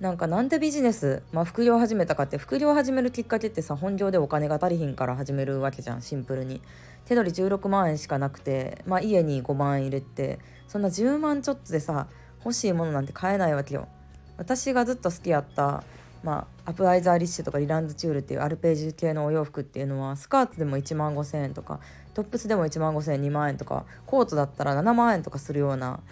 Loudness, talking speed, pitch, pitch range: -26 LUFS, 455 characters per minute, 155 Hz, 140-195 Hz